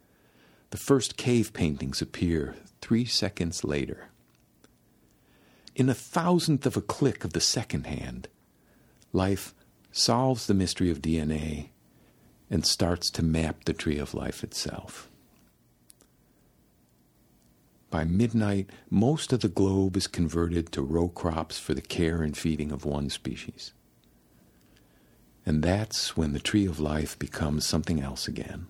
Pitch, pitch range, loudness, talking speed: 85 Hz, 75-105 Hz, -28 LUFS, 130 wpm